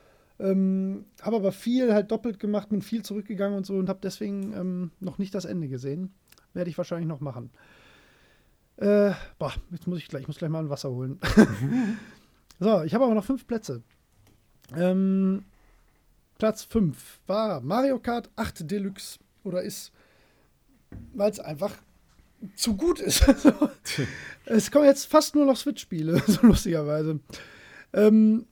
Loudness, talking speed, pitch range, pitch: -25 LUFS, 150 wpm, 175-220 Hz, 200 Hz